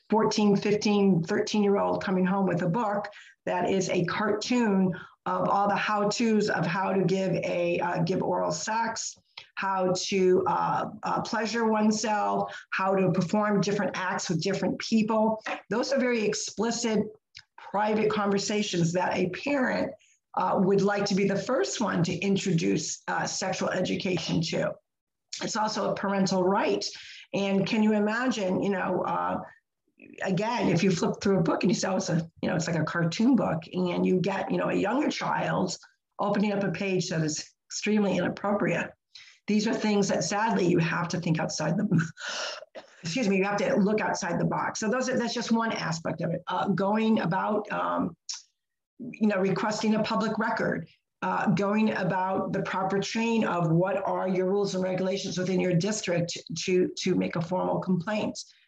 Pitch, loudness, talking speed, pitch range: 195 Hz, -27 LUFS, 180 wpm, 185-215 Hz